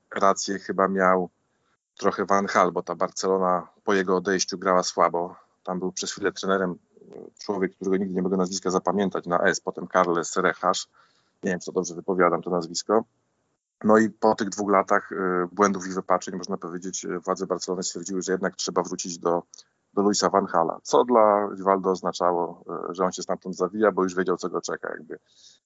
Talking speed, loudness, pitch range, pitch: 180 wpm, -25 LUFS, 90-95 Hz, 95 Hz